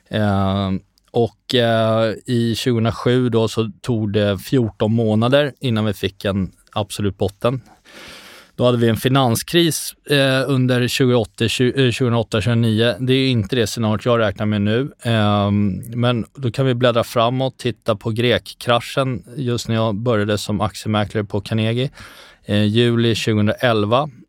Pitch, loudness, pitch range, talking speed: 115 Hz, -18 LUFS, 105-125 Hz, 145 wpm